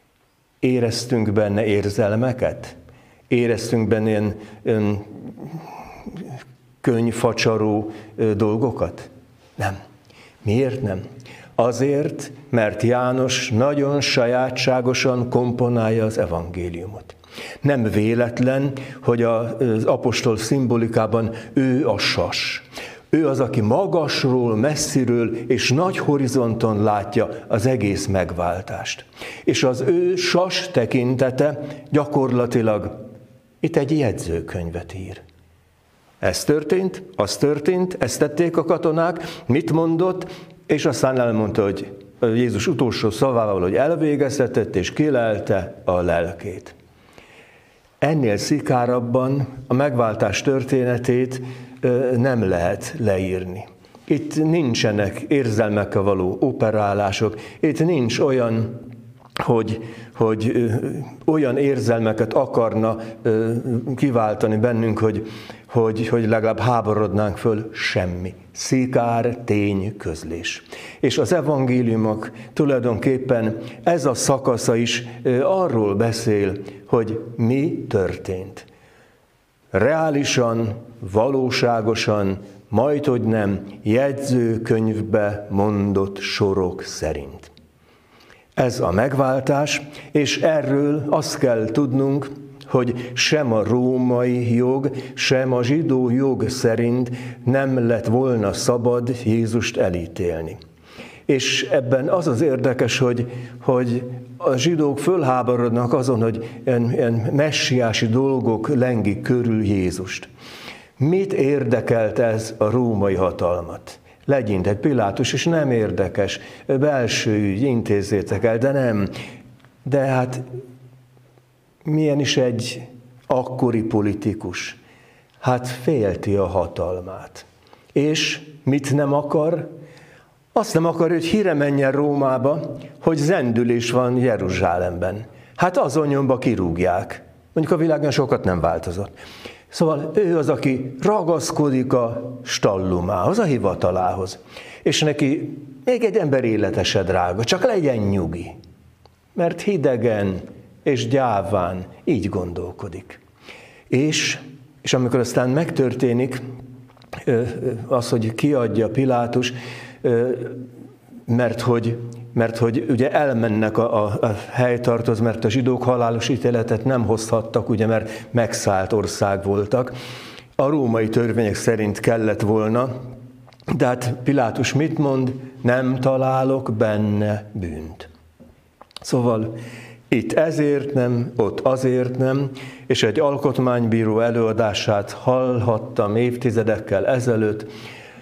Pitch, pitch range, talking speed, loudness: 120 Hz, 110-135 Hz, 100 wpm, -20 LUFS